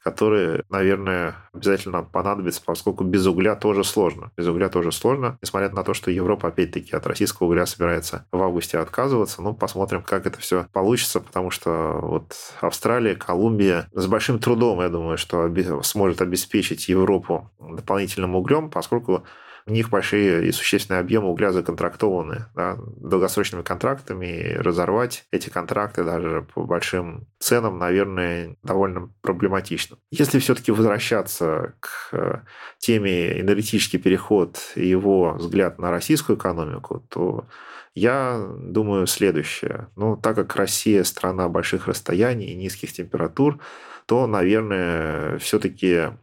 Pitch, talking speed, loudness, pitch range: 95 Hz, 130 wpm, -22 LUFS, 90-105 Hz